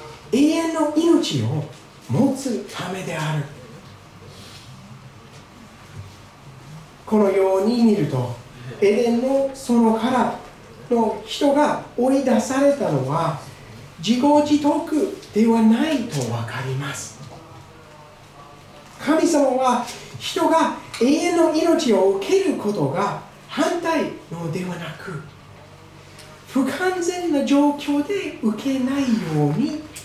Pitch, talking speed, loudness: 225 Hz, 180 characters per minute, -20 LUFS